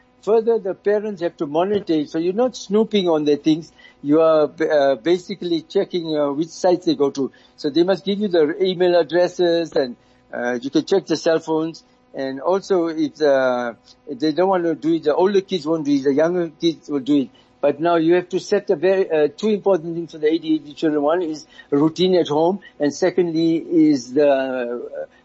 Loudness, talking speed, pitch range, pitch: -19 LUFS, 210 wpm, 150-190 Hz, 165 Hz